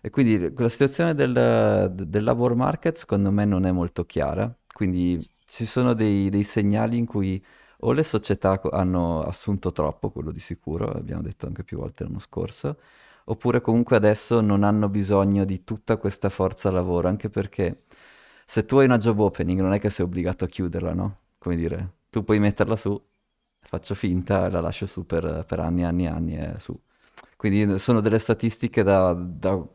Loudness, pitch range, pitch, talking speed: -24 LUFS, 90-110 Hz, 100 Hz, 185 wpm